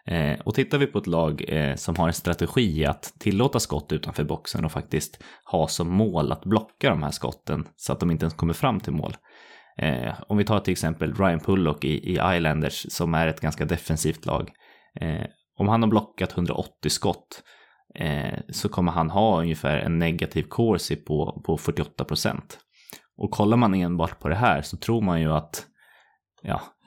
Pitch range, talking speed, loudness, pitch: 80-105 Hz, 175 wpm, -25 LUFS, 85 Hz